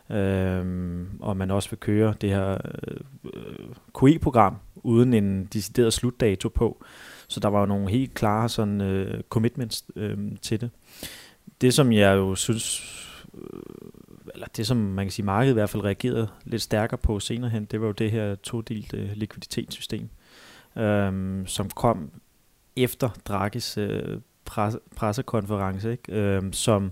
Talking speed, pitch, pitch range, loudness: 155 wpm, 105 Hz, 100-115 Hz, -25 LUFS